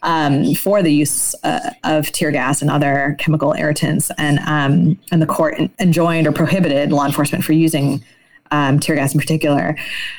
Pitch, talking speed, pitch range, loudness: 150 Hz, 170 wpm, 145-160 Hz, -16 LUFS